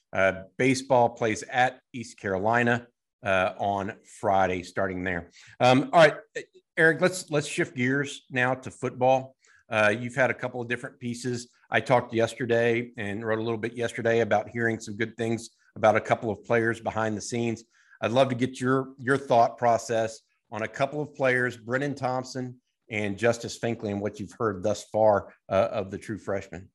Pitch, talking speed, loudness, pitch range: 120 Hz, 180 wpm, -26 LUFS, 110-130 Hz